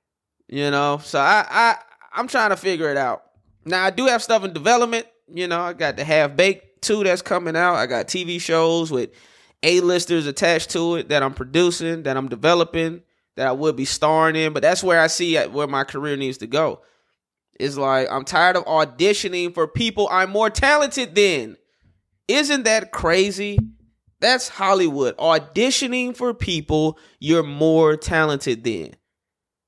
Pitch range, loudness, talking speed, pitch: 145-190 Hz, -19 LUFS, 170 wpm, 165 Hz